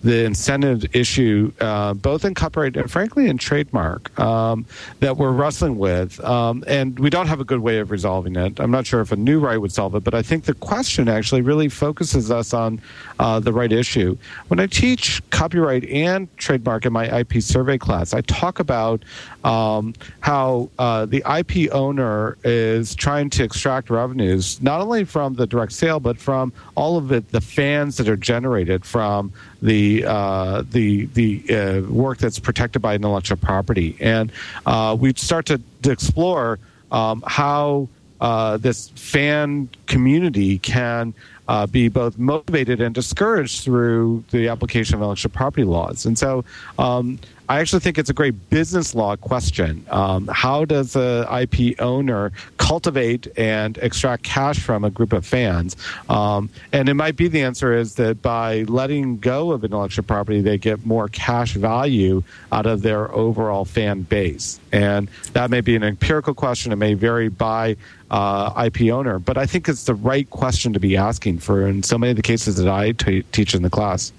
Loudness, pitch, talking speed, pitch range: -19 LUFS, 115 Hz, 180 wpm, 105-130 Hz